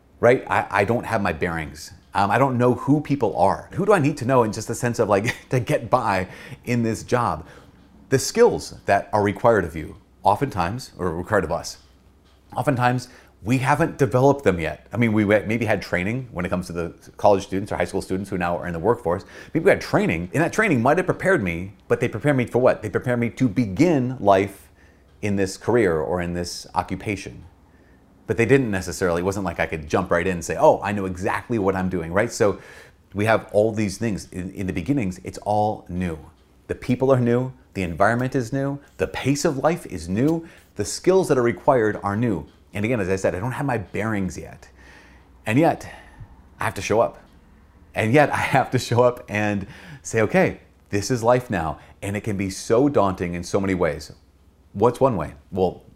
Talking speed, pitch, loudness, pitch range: 220 wpm, 100 Hz, -22 LUFS, 90-125 Hz